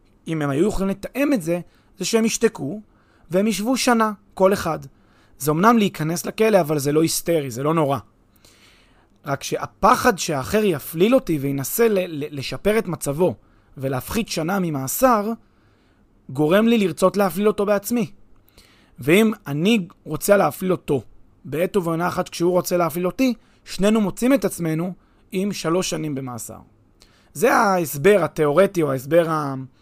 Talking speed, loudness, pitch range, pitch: 140 wpm, -20 LUFS, 140-200 Hz, 175 Hz